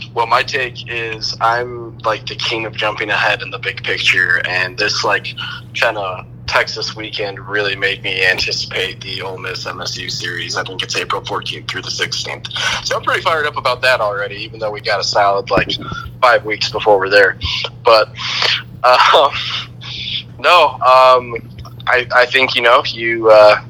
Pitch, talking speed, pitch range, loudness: 115 Hz, 175 wpm, 110-120 Hz, -15 LUFS